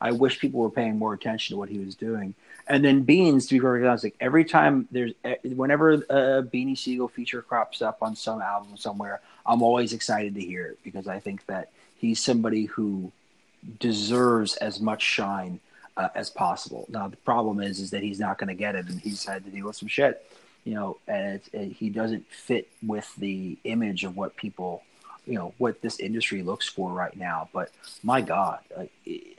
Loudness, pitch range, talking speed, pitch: -26 LUFS, 100-125 Hz, 210 wpm, 110 Hz